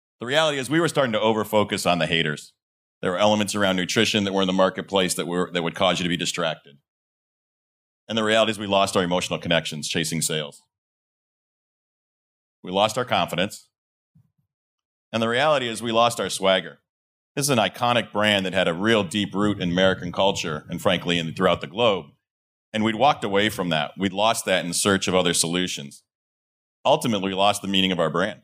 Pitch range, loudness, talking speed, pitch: 85-105 Hz, -22 LUFS, 205 wpm, 95 Hz